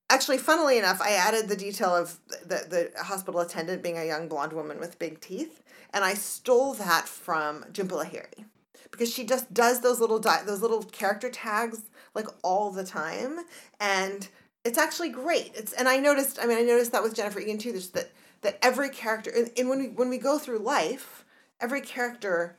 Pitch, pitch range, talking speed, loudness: 225 Hz, 195-255 Hz, 195 wpm, -27 LUFS